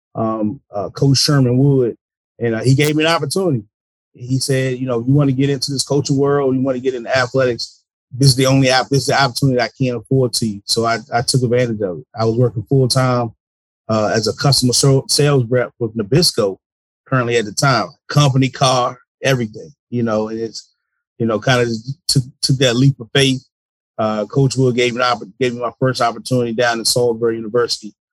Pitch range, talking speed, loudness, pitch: 115-135 Hz, 225 wpm, -16 LUFS, 125 Hz